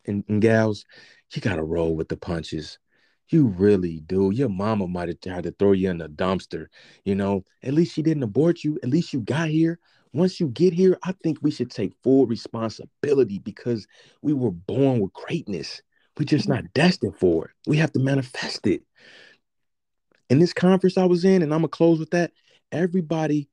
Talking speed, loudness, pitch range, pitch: 195 wpm, -23 LUFS, 100-165 Hz, 135 Hz